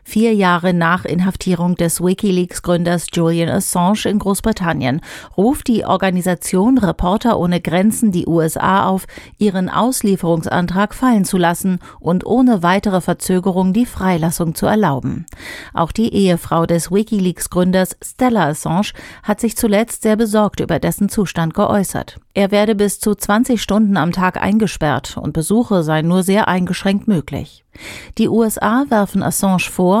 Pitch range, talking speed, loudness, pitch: 175-210 Hz, 140 wpm, -16 LUFS, 190 Hz